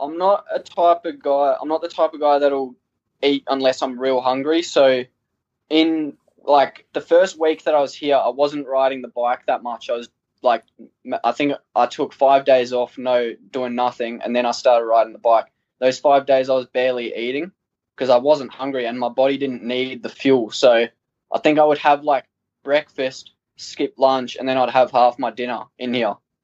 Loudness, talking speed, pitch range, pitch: -19 LUFS, 210 wpm, 125-145 Hz, 130 Hz